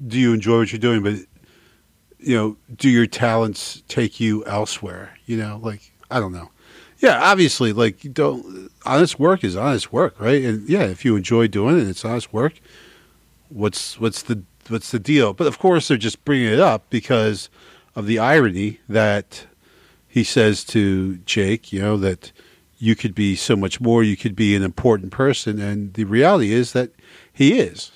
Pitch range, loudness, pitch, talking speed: 105-125 Hz, -19 LUFS, 115 Hz, 185 wpm